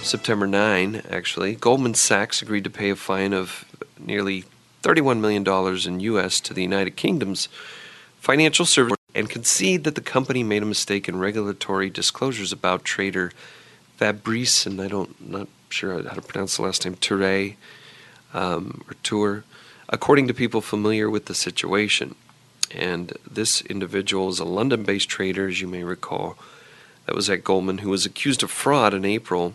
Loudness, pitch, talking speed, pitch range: -22 LUFS, 100 Hz, 170 wpm, 95-110 Hz